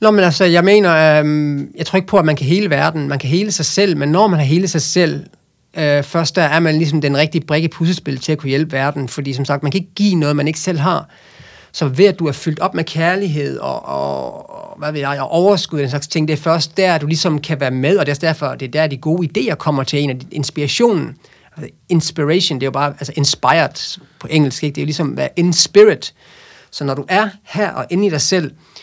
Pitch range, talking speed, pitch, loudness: 145-175 Hz, 270 wpm, 155 Hz, -15 LUFS